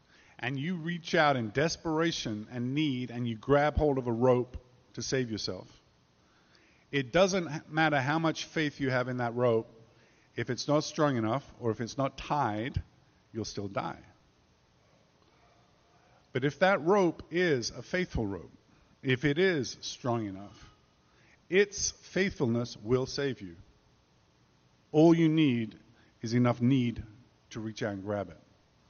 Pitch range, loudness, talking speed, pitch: 110-150 Hz, -30 LUFS, 150 wpm, 125 Hz